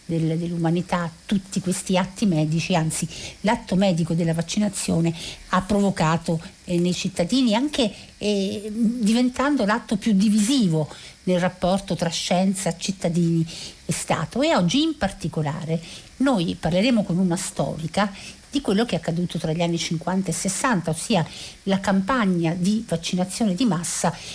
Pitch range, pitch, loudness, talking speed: 170-210 Hz, 185 Hz, -23 LUFS, 135 wpm